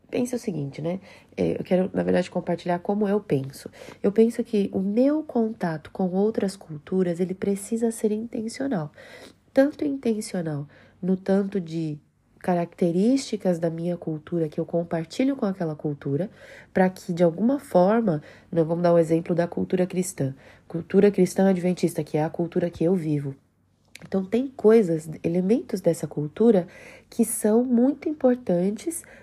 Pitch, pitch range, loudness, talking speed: 185 Hz, 165-220 Hz, -24 LUFS, 150 wpm